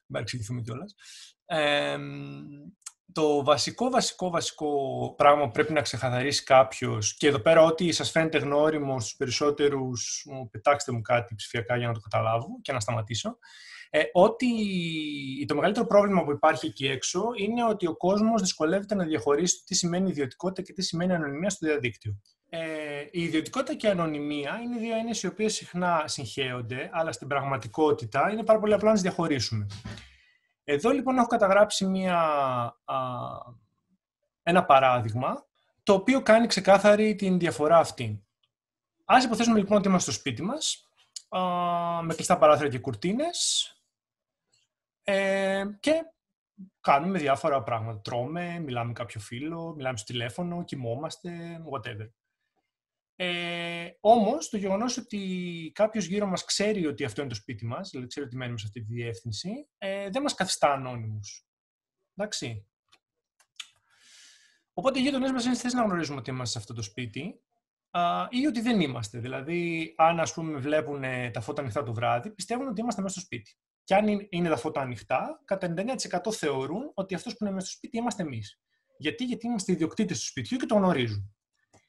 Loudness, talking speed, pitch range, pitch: -27 LUFS, 150 wpm, 130-200 Hz, 160 Hz